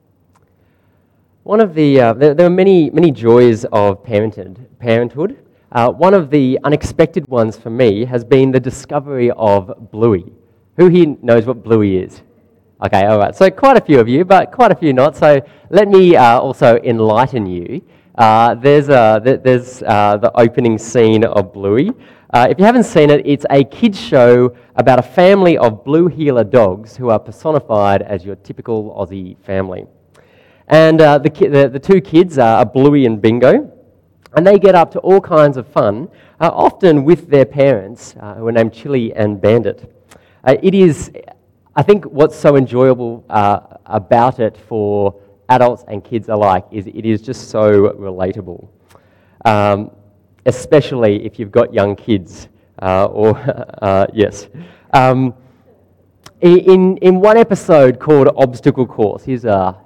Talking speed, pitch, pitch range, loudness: 165 wpm, 120 Hz, 105-145 Hz, -12 LUFS